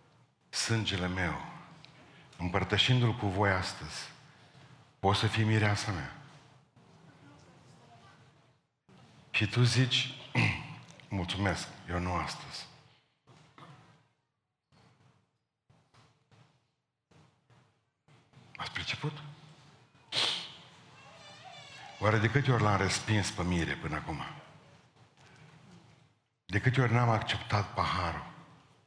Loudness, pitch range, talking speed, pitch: -31 LUFS, 110-145 Hz, 75 wpm, 130 Hz